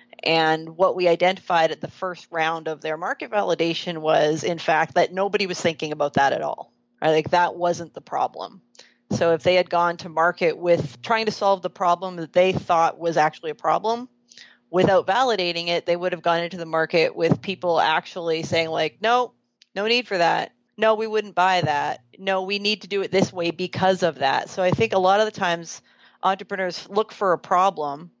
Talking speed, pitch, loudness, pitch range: 210 wpm, 175 Hz, -22 LUFS, 165-195 Hz